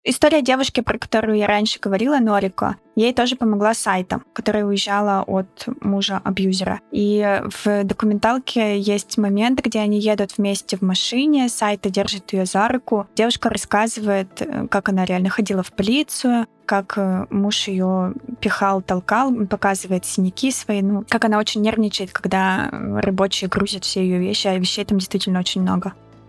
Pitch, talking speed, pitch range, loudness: 205 Hz, 150 wpm, 195-225 Hz, -20 LUFS